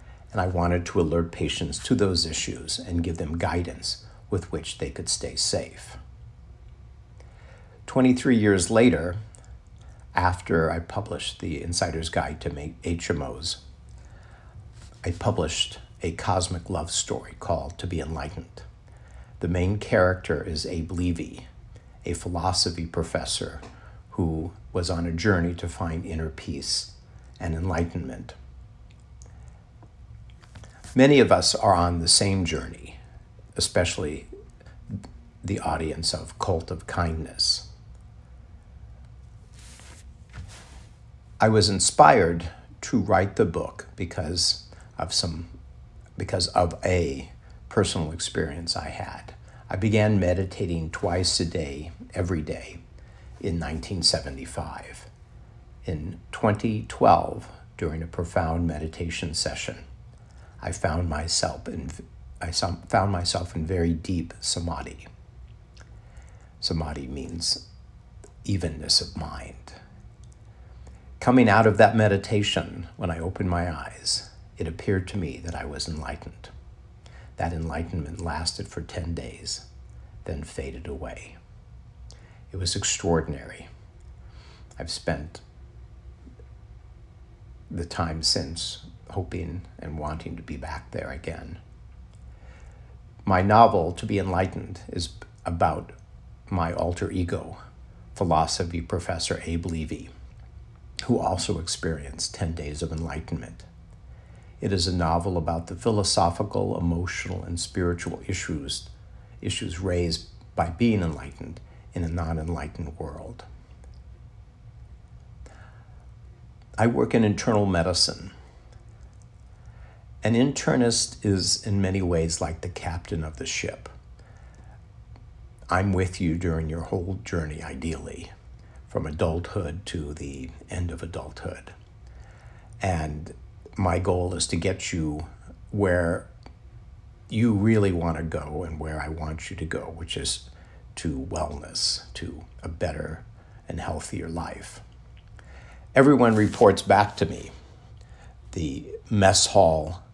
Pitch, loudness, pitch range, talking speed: 85 Hz, -26 LUFS, 80-95 Hz, 110 wpm